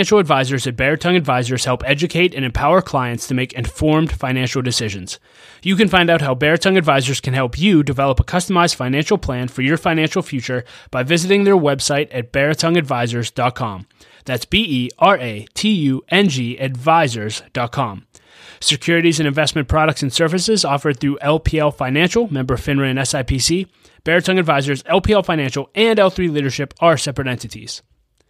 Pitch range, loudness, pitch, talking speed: 130-170 Hz, -17 LUFS, 140 Hz, 155 wpm